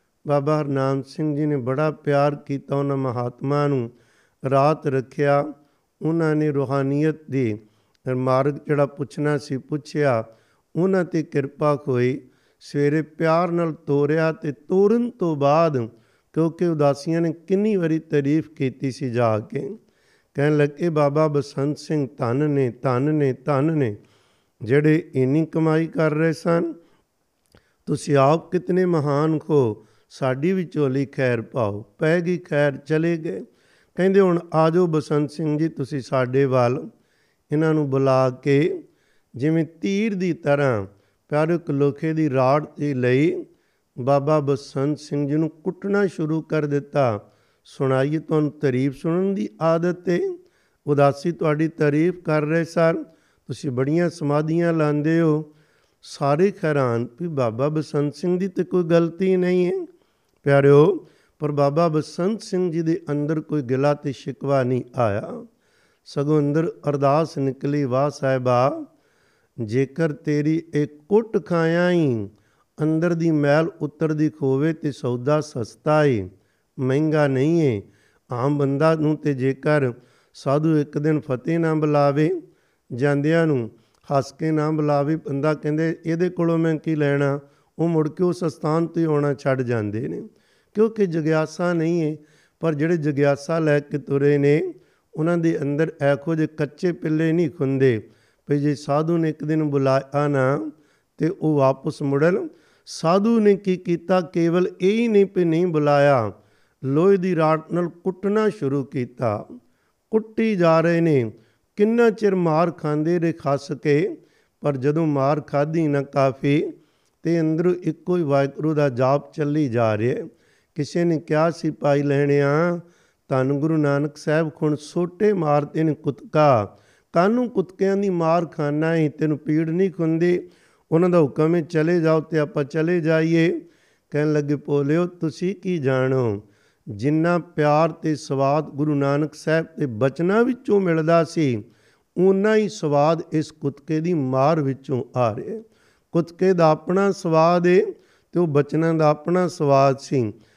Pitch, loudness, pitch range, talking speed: 150 Hz, -21 LUFS, 140-165 Hz, 145 wpm